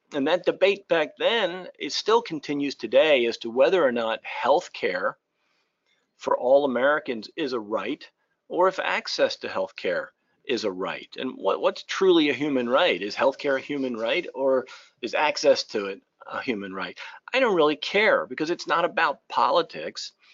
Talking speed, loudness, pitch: 170 wpm, -24 LUFS, 200 Hz